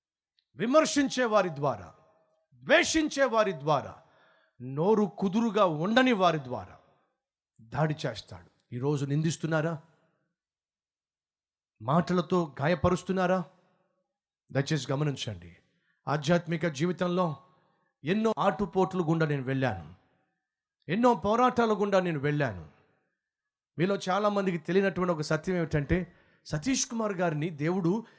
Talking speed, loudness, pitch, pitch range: 90 wpm, -28 LUFS, 170 Hz, 140-195 Hz